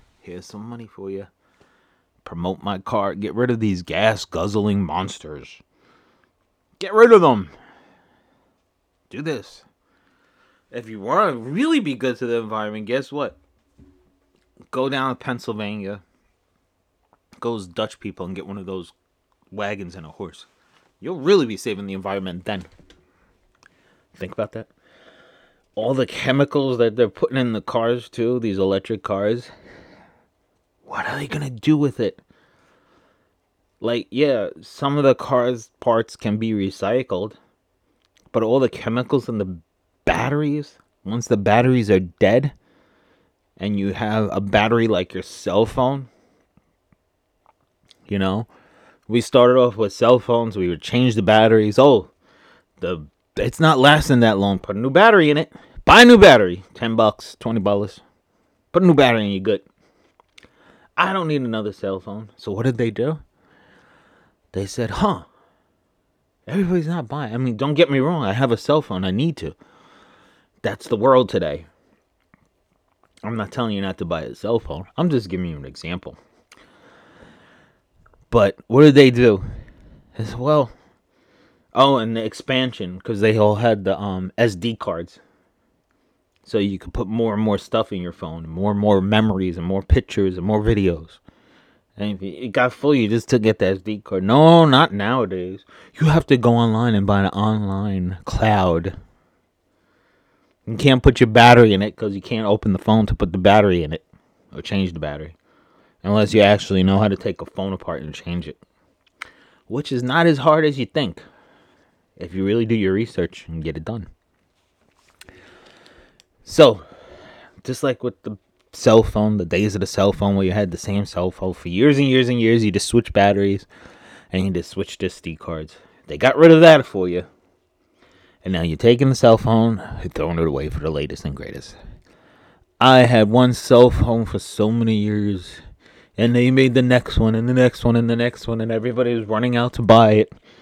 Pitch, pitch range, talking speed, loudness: 105 Hz, 95-125 Hz, 175 wpm, -18 LUFS